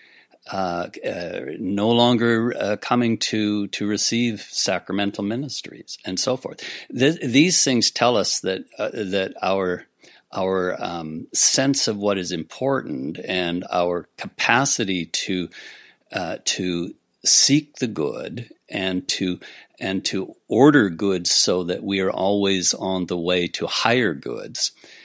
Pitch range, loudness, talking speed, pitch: 90-115 Hz, -21 LUFS, 135 wpm, 100 Hz